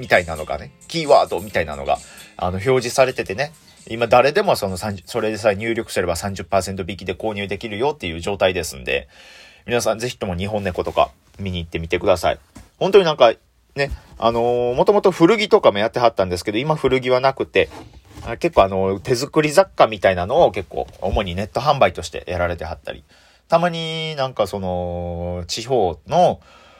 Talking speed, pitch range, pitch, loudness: 380 characters per minute, 95-130 Hz, 110 Hz, -19 LUFS